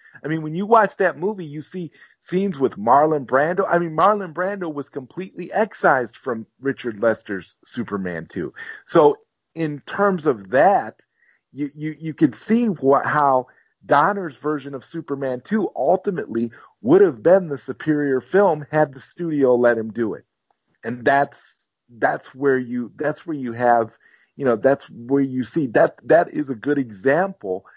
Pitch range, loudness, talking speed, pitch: 130-180 Hz, -20 LUFS, 165 wpm, 145 Hz